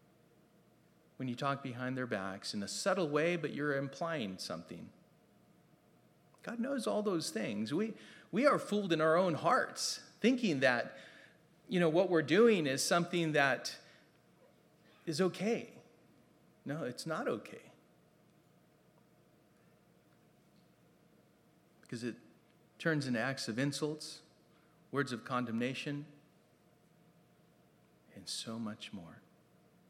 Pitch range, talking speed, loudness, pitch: 130-170 Hz, 115 wpm, -35 LUFS, 155 Hz